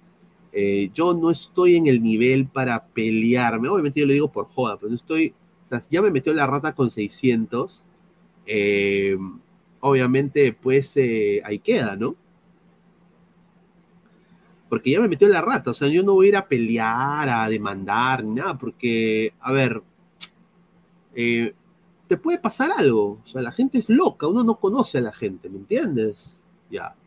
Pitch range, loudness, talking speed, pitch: 115-180 Hz, -21 LUFS, 175 wpm, 145 Hz